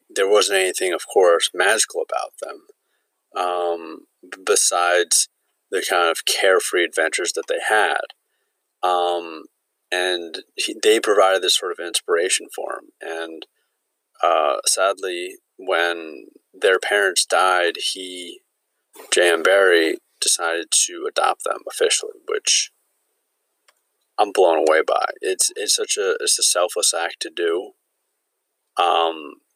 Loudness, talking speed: -19 LUFS, 120 wpm